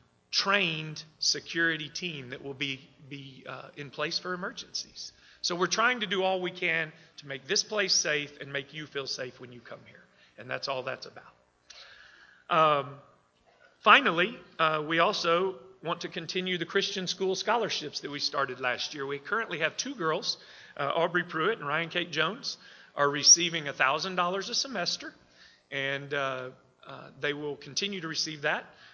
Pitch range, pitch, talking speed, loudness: 140-180 Hz, 155 Hz, 170 wpm, -28 LUFS